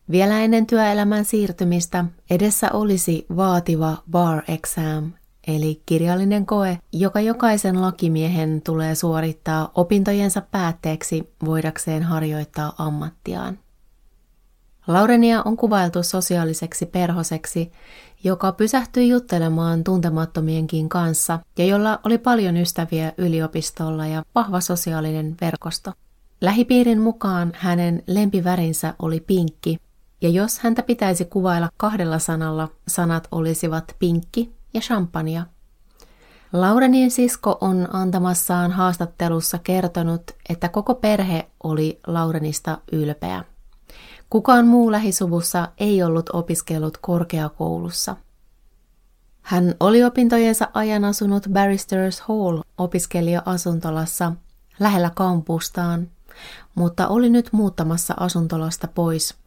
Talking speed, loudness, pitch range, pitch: 95 wpm, -20 LUFS, 165-200 Hz, 175 Hz